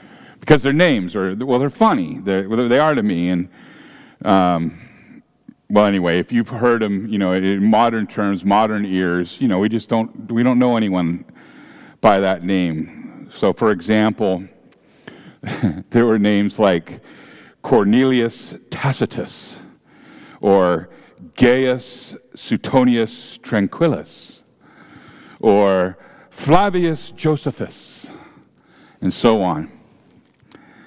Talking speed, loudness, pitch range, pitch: 115 wpm, -17 LUFS, 95-125 Hz, 110 Hz